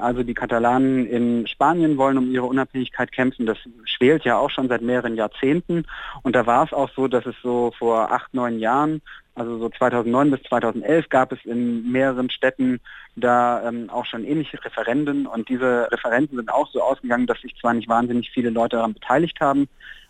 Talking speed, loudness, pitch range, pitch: 190 wpm, -21 LUFS, 120-135 Hz, 125 Hz